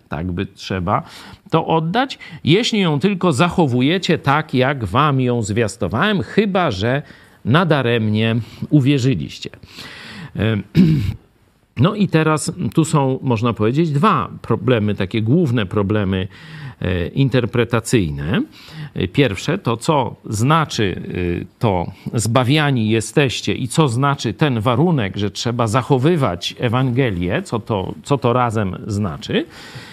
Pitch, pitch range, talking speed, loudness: 130 Hz, 110-155 Hz, 105 wpm, -18 LUFS